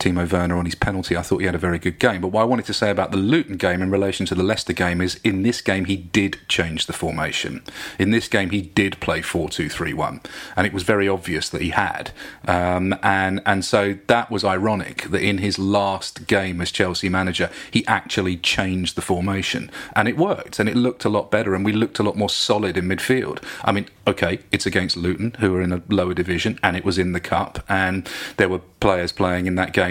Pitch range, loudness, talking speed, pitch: 90-100 Hz, -21 LUFS, 240 wpm, 95 Hz